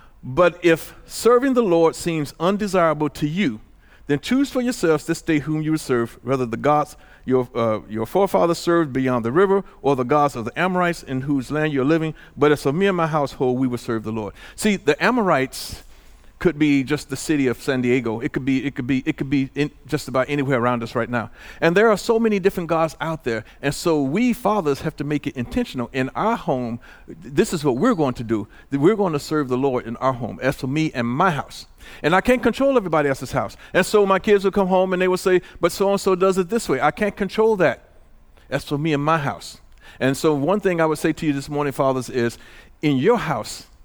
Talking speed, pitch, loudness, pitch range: 240 wpm, 150 Hz, -21 LUFS, 130-180 Hz